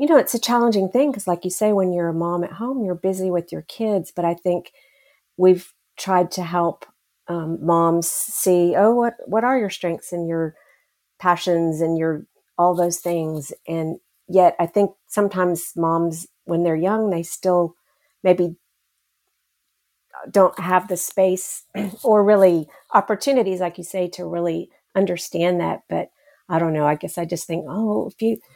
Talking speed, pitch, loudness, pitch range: 175 wpm, 180 Hz, -21 LUFS, 170-205 Hz